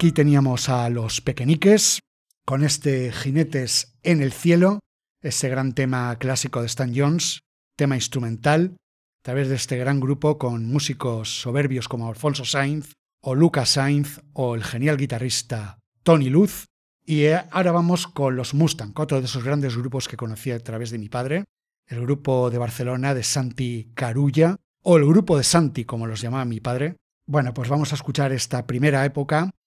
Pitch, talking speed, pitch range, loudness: 135 Hz, 170 wpm, 125-150 Hz, -22 LUFS